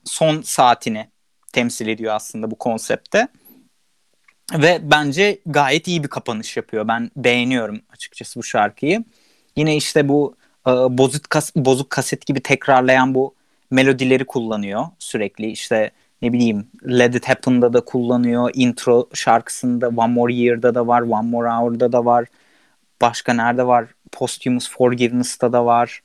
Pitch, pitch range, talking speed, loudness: 125 Hz, 120-135 Hz, 140 wpm, -18 LUFS